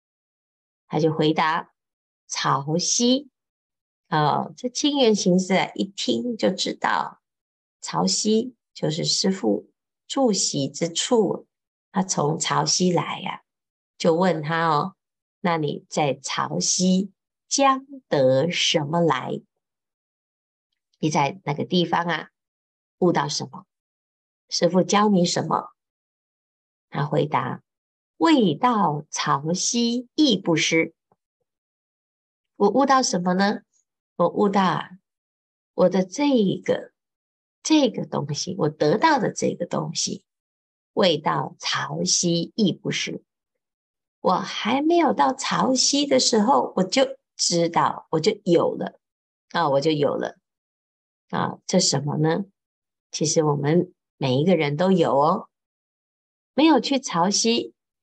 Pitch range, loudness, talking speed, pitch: 160-230 Hz, -22 LUFS, 155 characters per minute, 180 Hz